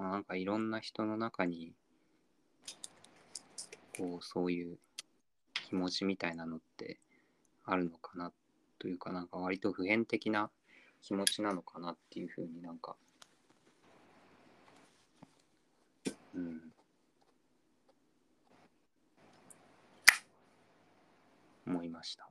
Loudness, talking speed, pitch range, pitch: -37 LUFS, 165 characters per minute, 85-100 Hz, 90 Hz